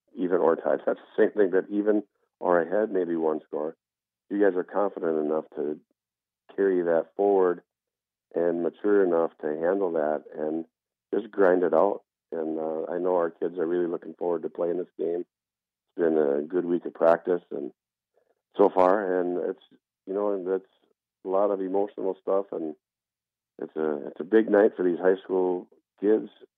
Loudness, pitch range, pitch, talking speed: -26 LUFS, 80-95 Hz, 90 Hz, 185 wpm